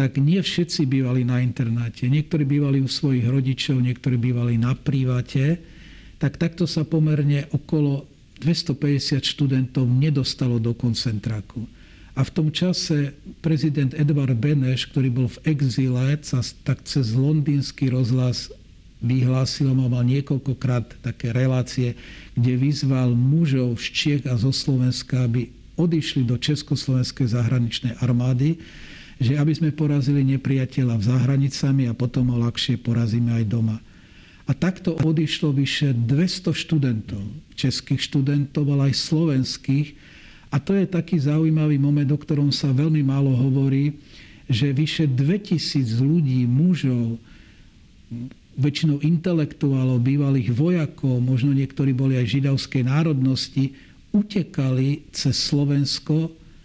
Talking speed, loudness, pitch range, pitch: 125 wpm, -22 LUFS, 125-150 Hz, 135 Hz